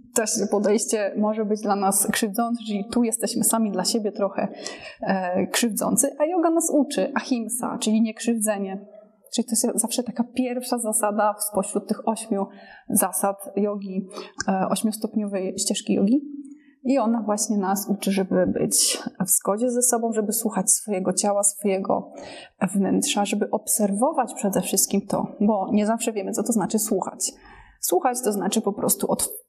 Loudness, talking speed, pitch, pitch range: -23 LUFS, 155 wpm, 215 Hz, 200-235 Hz